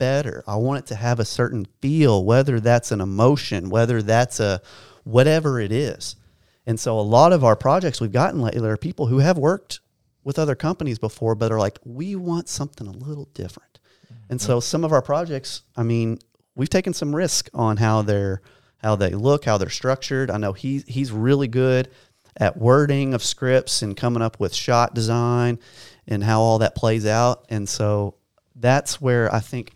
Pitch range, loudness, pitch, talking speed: 110-135 Hz, -21 LUFS, 120 Hz, 195 wpm